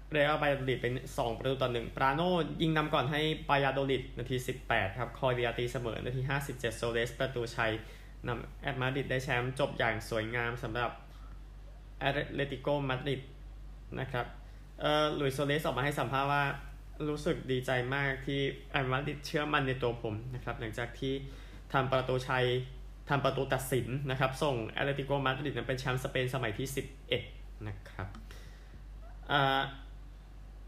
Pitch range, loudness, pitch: 120-140 Hz, -33 LUFS, 130 Hz